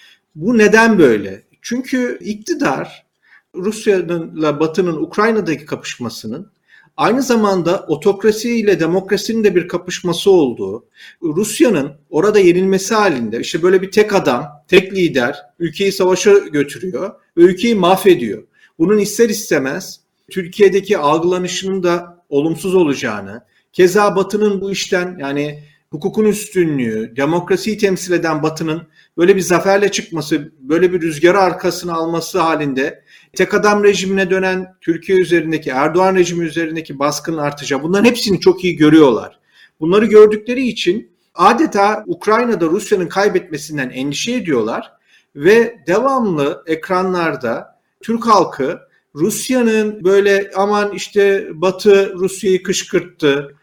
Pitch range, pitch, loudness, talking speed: 165-210 Hz, 190 Hz, -15 LUFS, 110 wpm